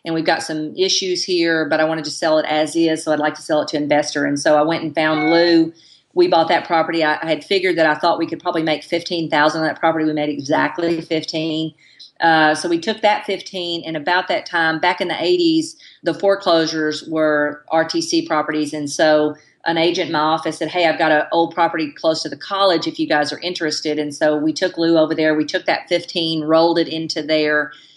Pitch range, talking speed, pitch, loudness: 155-170 Hz, 235 wpm, 160 Hz, -18 LUFS